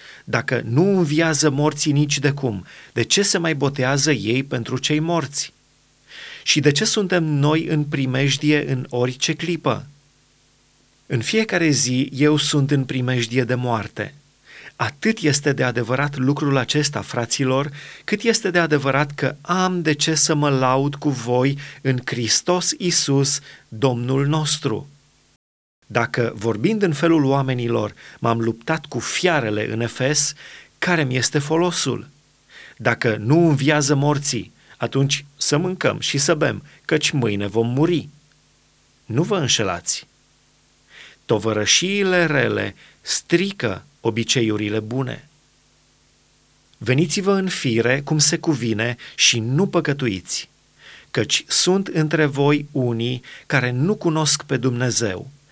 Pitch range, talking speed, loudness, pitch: 125-155 Hz, 125 wpm, -19 LUFS, 140 Hz